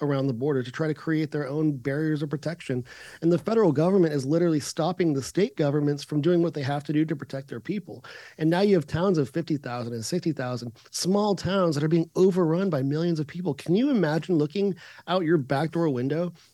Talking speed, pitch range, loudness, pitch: 220 wpm, 145-175 Hz, -26 LUFS, 155 Hz